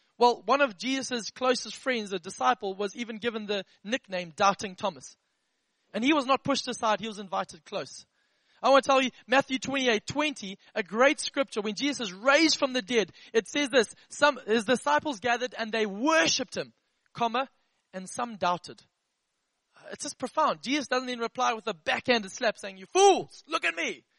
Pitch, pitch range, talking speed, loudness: 245 Hz, 215-270 Hz, 190 wpm, -27 LUFS